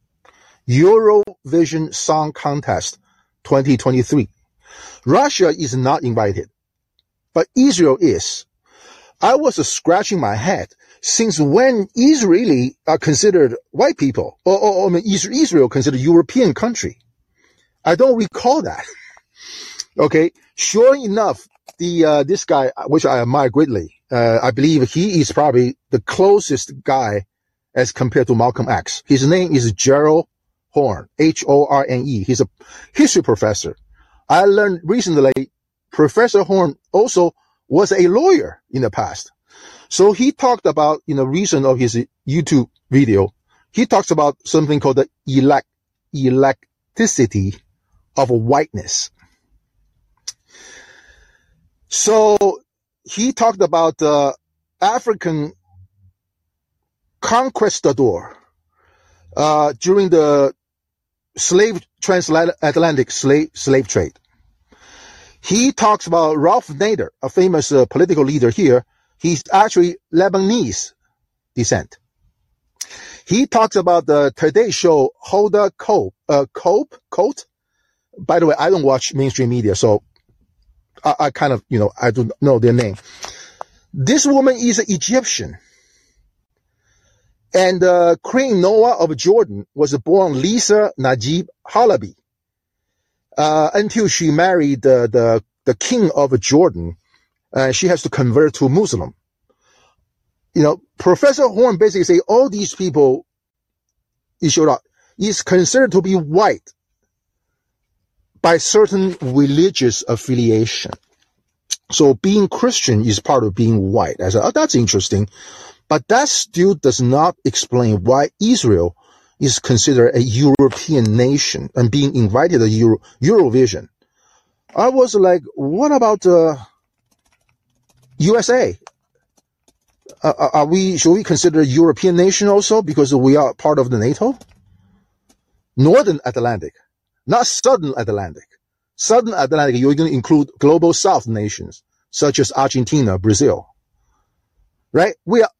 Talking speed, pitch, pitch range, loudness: 120 wpm, 150 Hz, 125-200 Hz, -15 LUFS